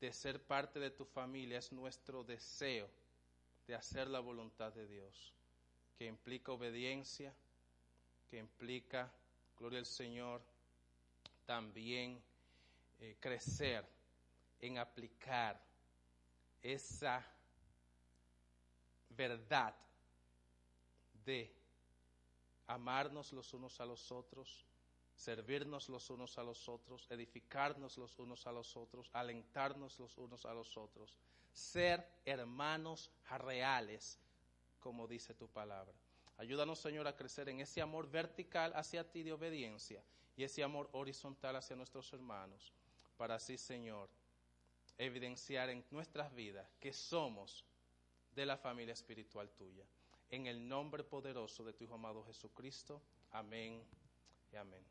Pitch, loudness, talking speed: 120 Hz, -47 LUFS, 115 wpm